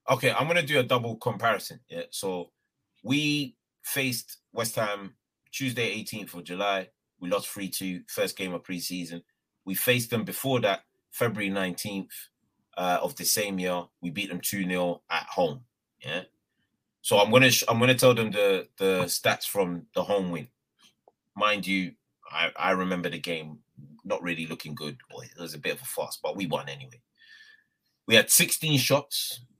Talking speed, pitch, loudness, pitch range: 175 wpm, 100 Hz, -27 LUFS, 90-130 Hz